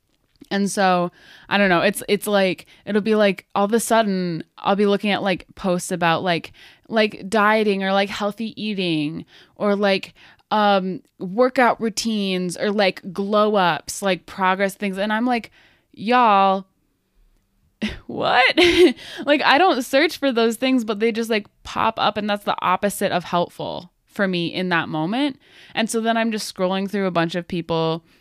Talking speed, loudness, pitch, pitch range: 170 wpm, -20 LUFS, 200 Hz, 185-225 Hz